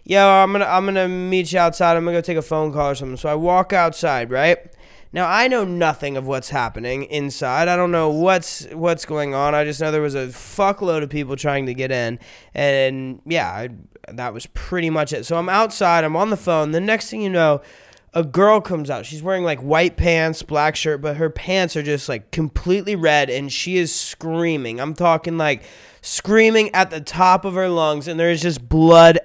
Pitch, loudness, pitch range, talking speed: 165 Hz, -18 LUFS, 150-180 Hz, 220 wpm